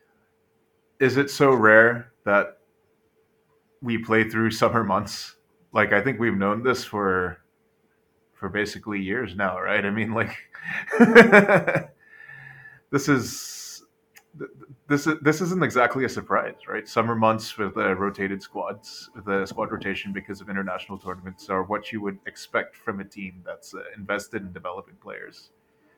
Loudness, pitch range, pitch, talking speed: -22 LUFS, 100-130 Hz, 110 Hz, 145 wpm